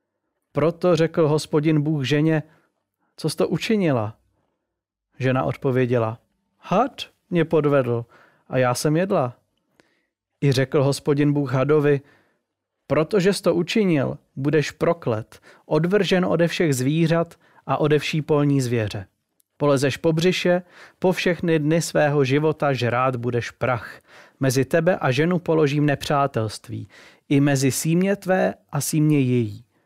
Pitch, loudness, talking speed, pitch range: 150 Hz, -21 LUFS, 125 wpm, 130-165 Hz